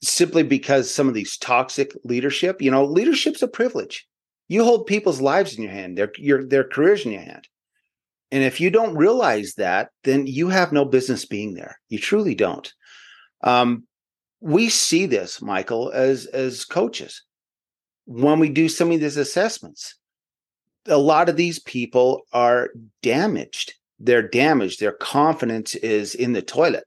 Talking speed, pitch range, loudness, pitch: 160 wpm, 125-175 Hz, -20 LUFS, 140 Hz